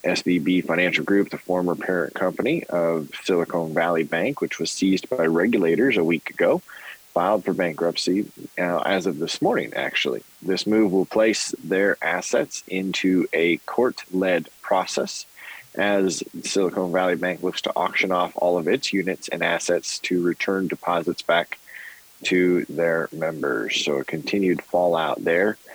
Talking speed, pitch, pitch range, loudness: 150 wpm, 90 Hz, 85-95 Hz, -23 LUFS